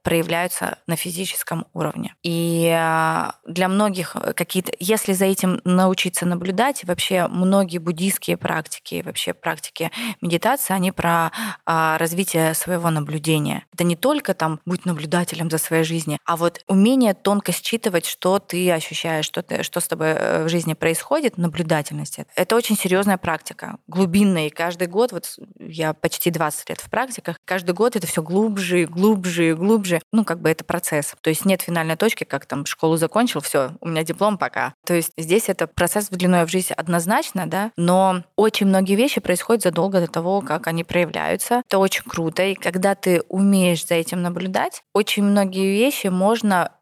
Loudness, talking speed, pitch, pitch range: -20 LUFS, 165 wpm, 180 Hz, 165-195 Hz